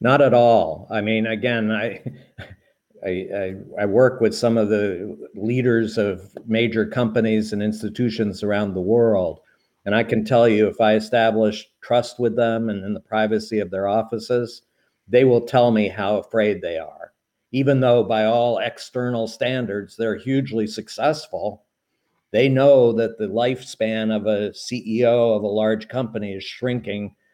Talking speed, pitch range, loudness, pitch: 160 wpm, 105-120 Hz, -20 LUFS, 110 Hz